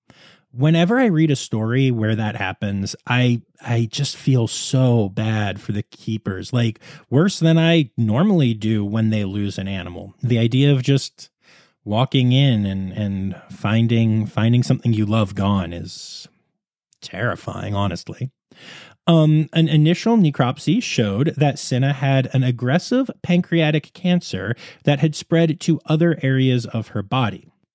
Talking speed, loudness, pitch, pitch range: 145 wpm, -19 LUFS, 125 Hz, 110-155 Hz